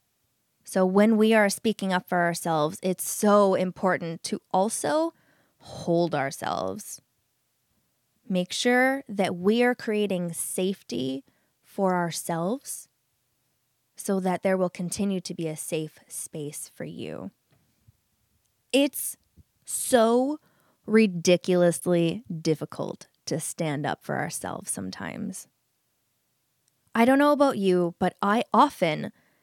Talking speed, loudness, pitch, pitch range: 110 wpm, -25 LUFS, 180 Hz, 160-210 Hz